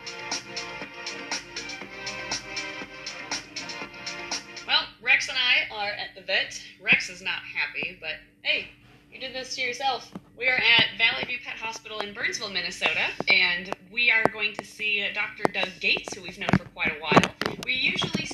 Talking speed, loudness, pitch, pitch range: 155 wpm, -25 LUFS, 220 Hz, 200-245 Hz